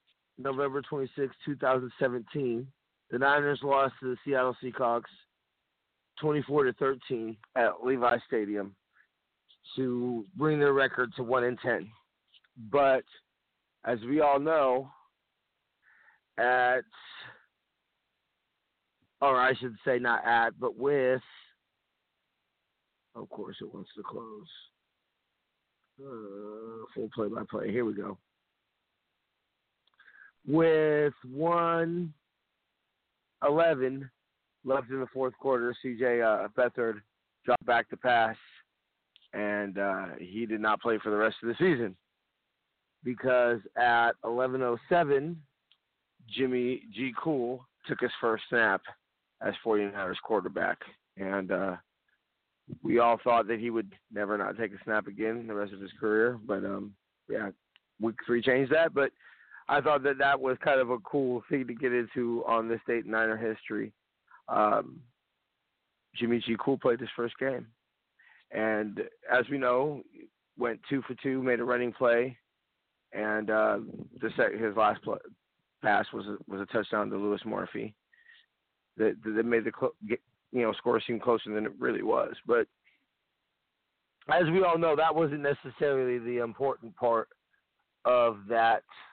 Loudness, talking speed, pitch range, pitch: -30 LUFS, 135 wpm, 115-135 Hz, 125 Hz